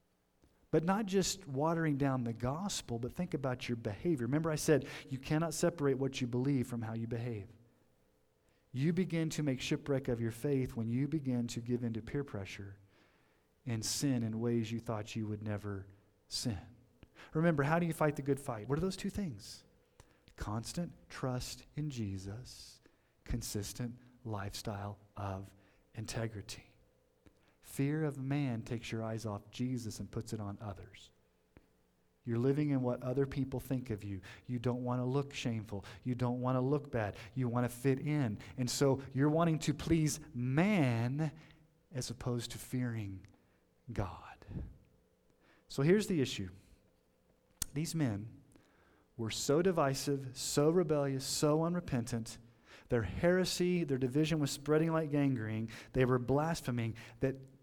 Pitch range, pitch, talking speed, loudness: 110-145 Hz, 125 Hz, 155 wpm, -36 LUFS